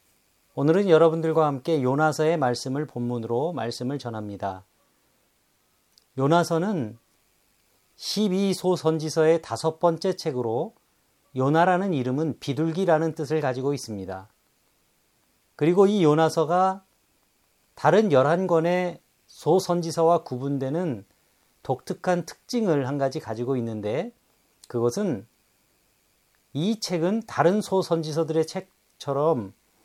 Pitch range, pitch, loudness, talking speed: 130-170 Hz, 155 Hz, -24 LUFS, 235 characters per minute